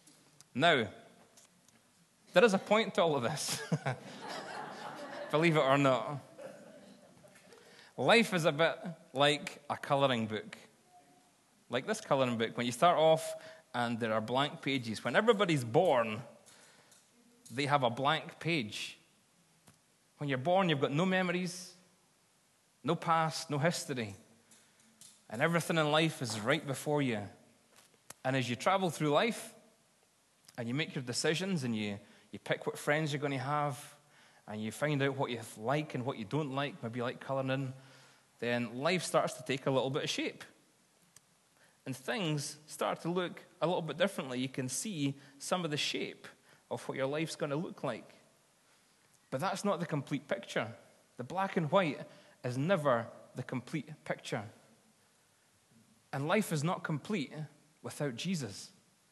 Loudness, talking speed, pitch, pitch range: -34 LUFS, 155 wpm, 150 Hz, 130-175 Hz